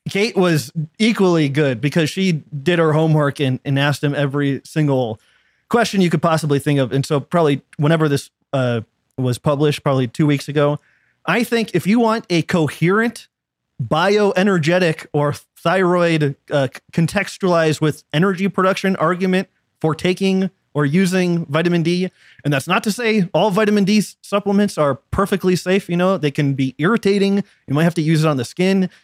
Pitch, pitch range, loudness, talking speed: 165 Hz, 145-190 Hz, -18 LUFS, 170 wpm